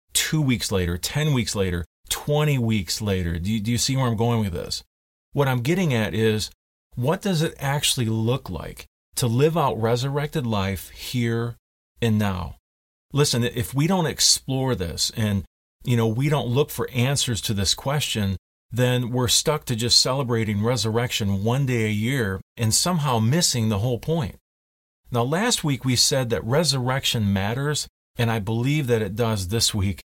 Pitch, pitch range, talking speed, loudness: 115 Hz, 100-135 Hz, 175 wpm, -23 LUFS